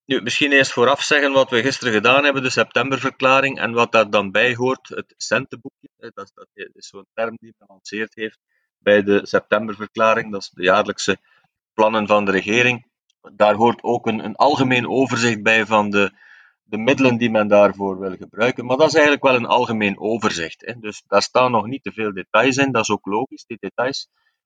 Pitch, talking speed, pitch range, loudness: 115 Hz, 200 wpm, 105-130 Hz, -18 LUFS